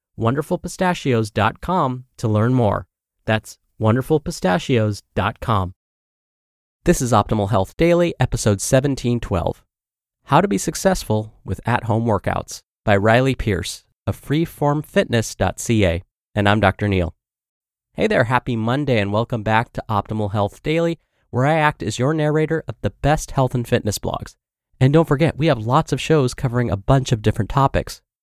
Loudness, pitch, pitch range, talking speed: -20 LUFS, 120 Hz, 105-145 Hz, 145 wpm